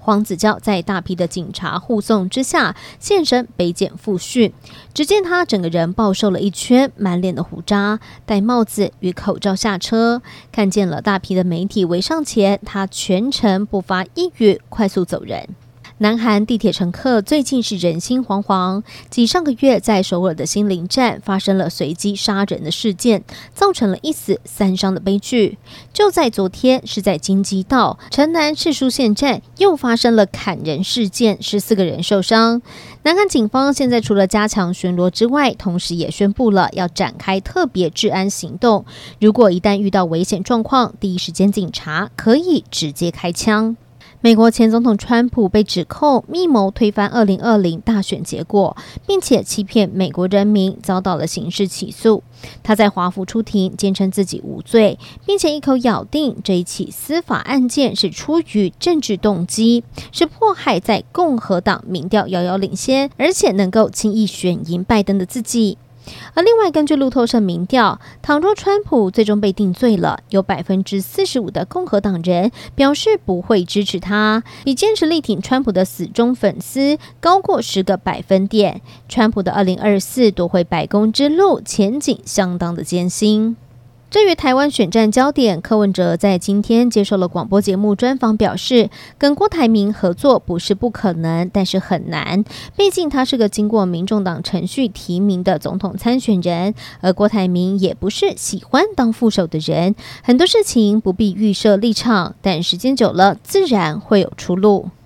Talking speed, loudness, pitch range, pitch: 260 characters per minute, -16 LUFS, 185-240 Hz, 205 Hz